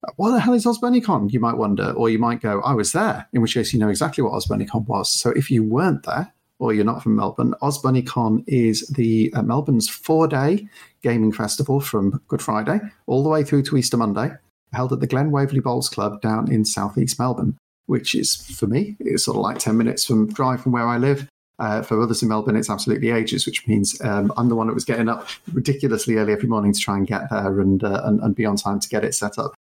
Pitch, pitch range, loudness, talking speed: 115 Hz, 110-140 Hz, -20 LUFS, 240 wpm